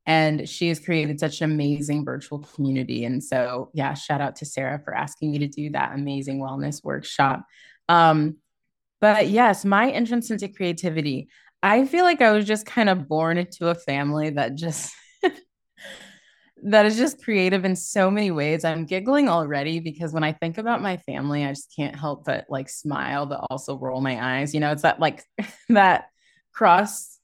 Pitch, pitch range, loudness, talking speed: 160 Hz, 145-190 Hz, -23 LUFS, 185 wpm